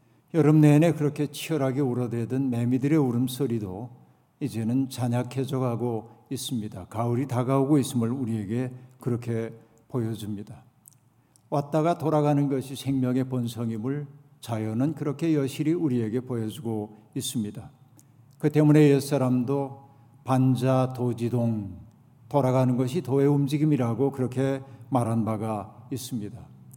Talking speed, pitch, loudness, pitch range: 300 characters per minute, 130 Hz, -26 LUFS, 120-140 Hz